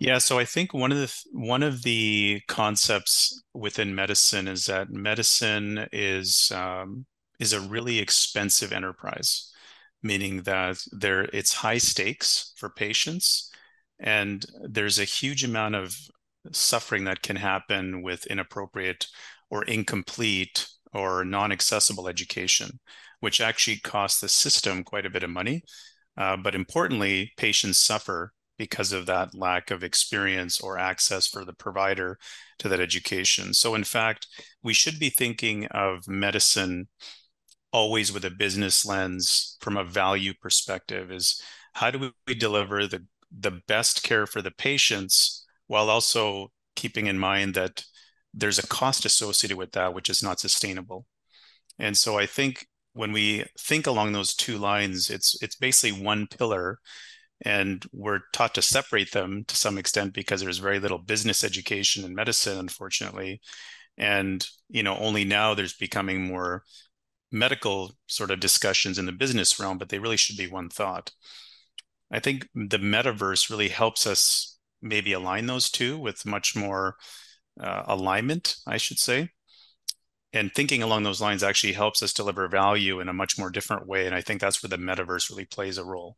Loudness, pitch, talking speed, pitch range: -24 LUFS, 100 Hz, 160 wpm, 95-110 Hz